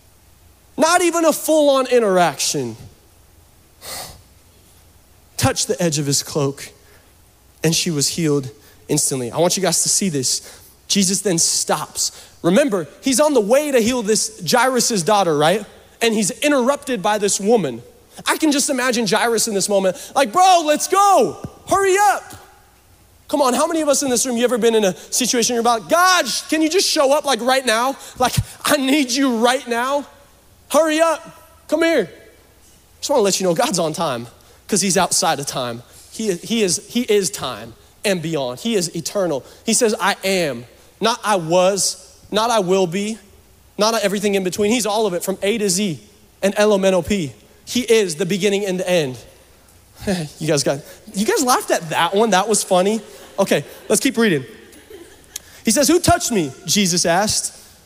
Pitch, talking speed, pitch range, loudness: 200 Hz, 185 wpm, 155-245 Hz, -17 LUFS